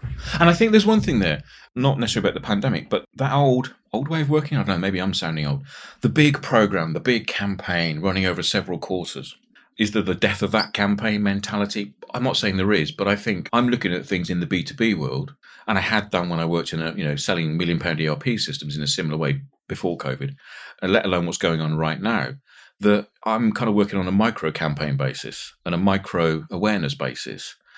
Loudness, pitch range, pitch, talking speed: -22 LUFS, 80-110 Hz, 95 Hz, 225 wpm